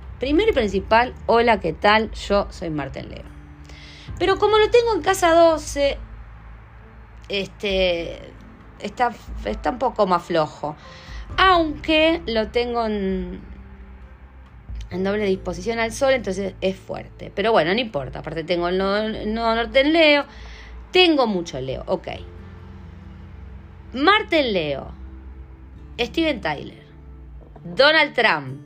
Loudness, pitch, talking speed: -20 LUFS, 195 Hz, 125 wpm